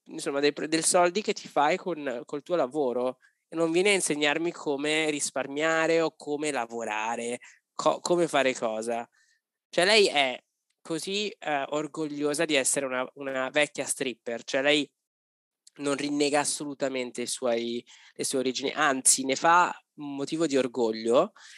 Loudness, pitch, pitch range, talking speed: -27 LUFS, 145 Hz, 130-160 Hz, 150 wpm